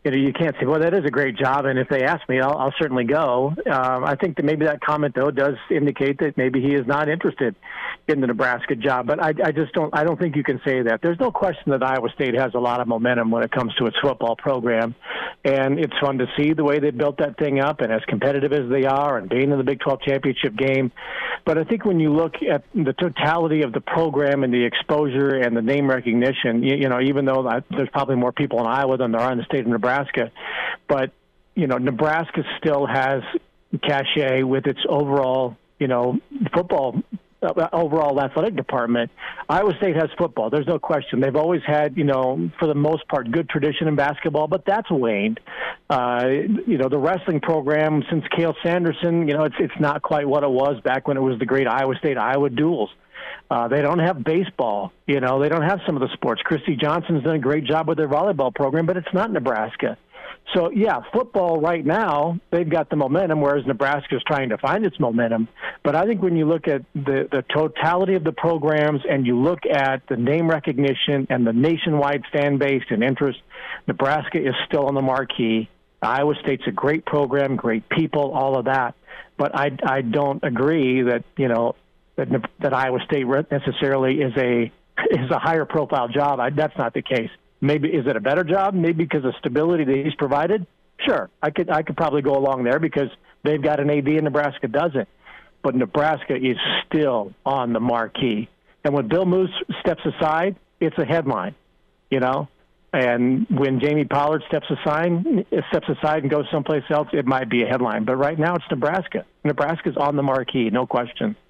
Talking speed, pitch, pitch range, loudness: 210 wpm, 145 Hz, 135-160 Hz, -21 LUFS